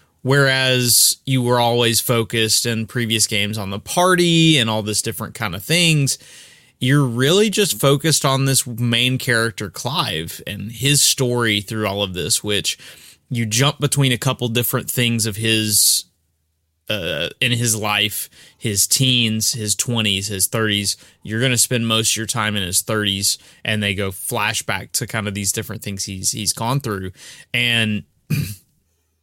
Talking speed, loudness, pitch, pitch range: 165 wpm, -17 LUFS, 115 Hz, 105-130 Hz